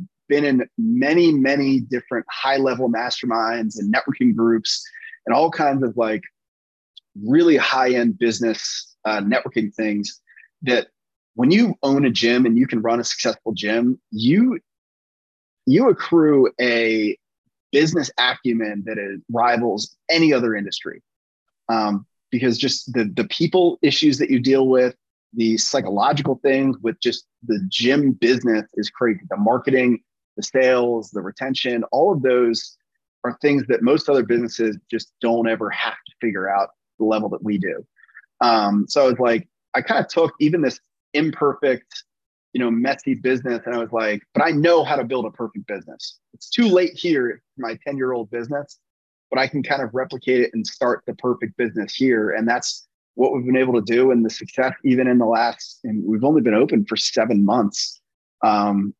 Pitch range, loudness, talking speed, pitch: 115-140 Hz, -20 LUFS, 170 wpm, 125 Hz